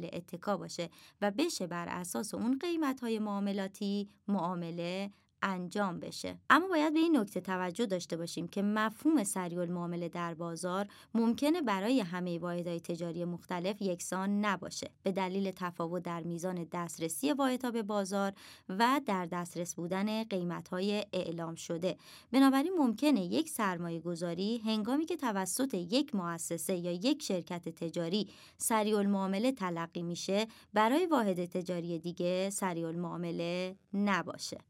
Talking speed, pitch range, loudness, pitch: 130 wpm, 175-220 Hz, -34 LUFS, 190 Hz